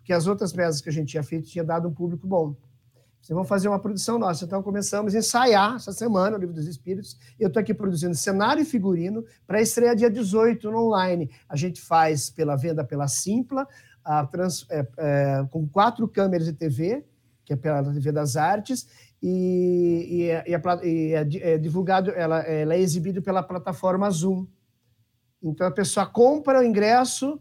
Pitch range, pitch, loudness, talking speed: 155-205 Hz, 180 Hz, -24 LUFS, 195 wpm